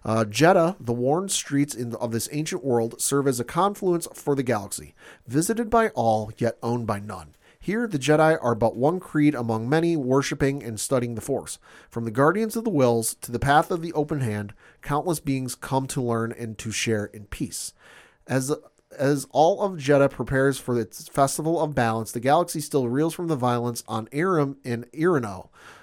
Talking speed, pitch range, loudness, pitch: 195 wpm, 115-155 Hz, -24 LUFS, 135 Hz